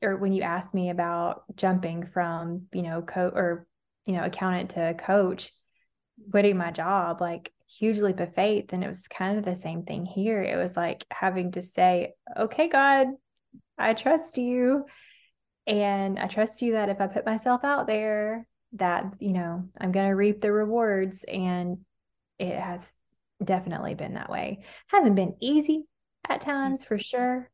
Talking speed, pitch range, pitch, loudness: 170 wpm, 180-220 Hz, 195 Hz, -27 LUFS